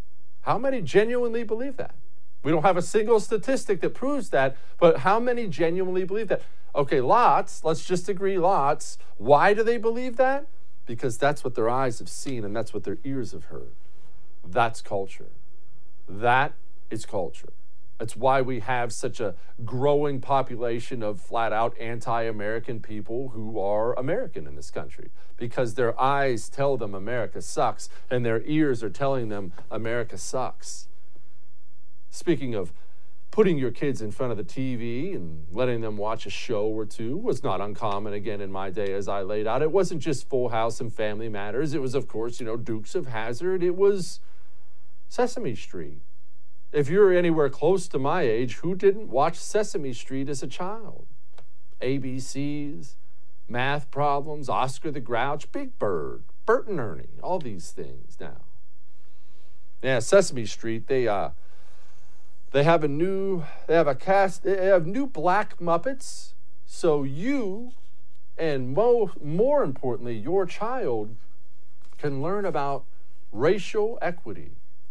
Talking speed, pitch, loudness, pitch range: 150 wpm, 135 Hz, -26 LUFS, 115-185 Hz